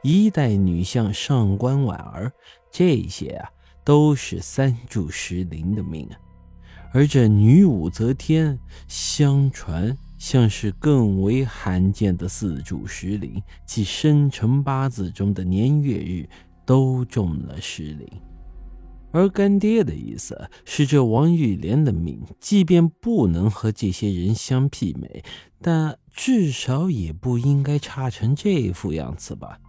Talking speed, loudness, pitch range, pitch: 185 characters per minute, -21 LUFS, 90-140 Hz, 110 Hz